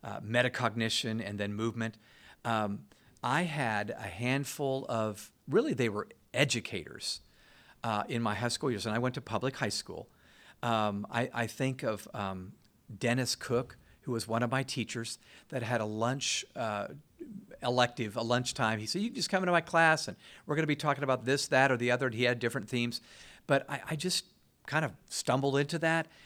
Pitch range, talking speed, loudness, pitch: 115-135 Hz, 195 wpm, -32 LUFS, 120 Hz